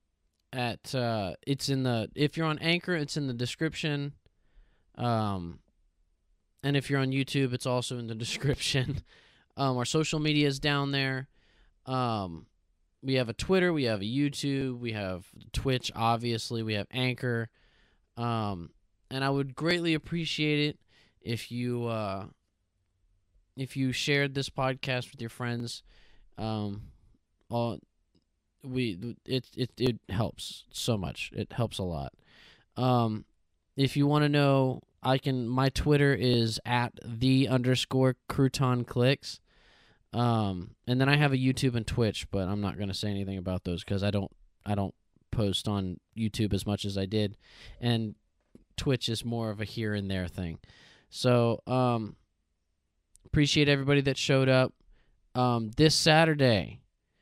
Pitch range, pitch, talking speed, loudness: 100-135 Hz, 120 Hz, 150 wpm, -29 LUFS